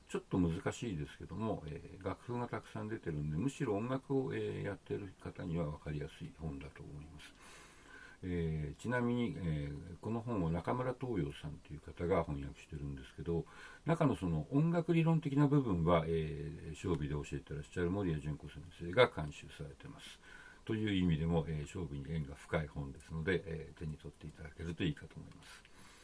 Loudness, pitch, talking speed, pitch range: -38 LUFS, 85 Hz, 390 characters per minute, 75-110 Hz